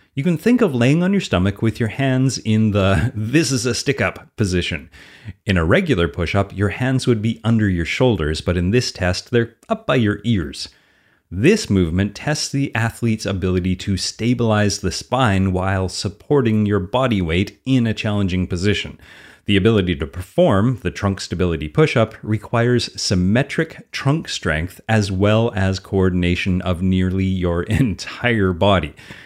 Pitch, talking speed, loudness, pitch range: 105 Hz, 165 wpm, -19 LUFS, 95-120 Hz